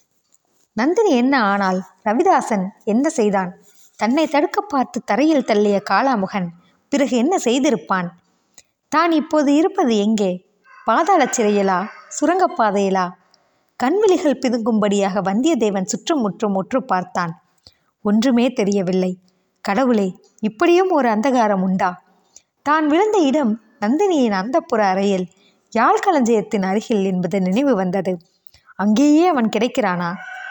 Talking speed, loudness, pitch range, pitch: 100 wpm, -18 LUFS, 195-275 Hz, 220 Hz